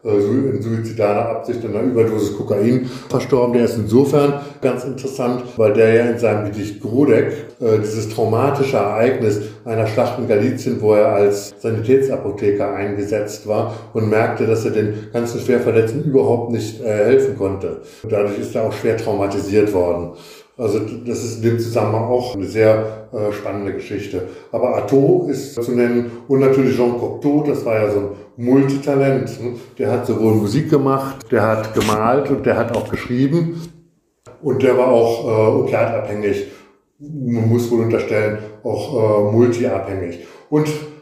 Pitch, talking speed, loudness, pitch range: 115 Hz, 160 wpm, -18 LUFS, 105-130 Hz